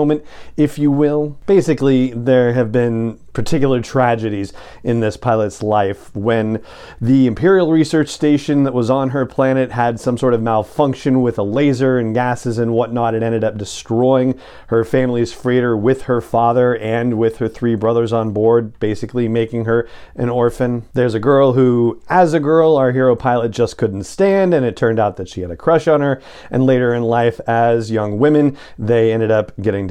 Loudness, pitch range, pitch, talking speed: -16 LUFS, 115-135 Hz, 120 Hz, 185 wpm